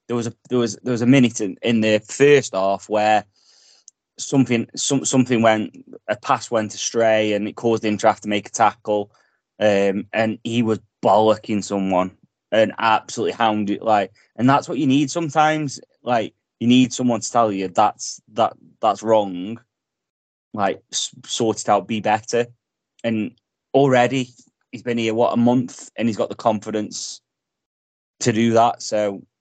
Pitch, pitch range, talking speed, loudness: 110 Hz, 105-120 Hz, 165 wpm, -20 LUFS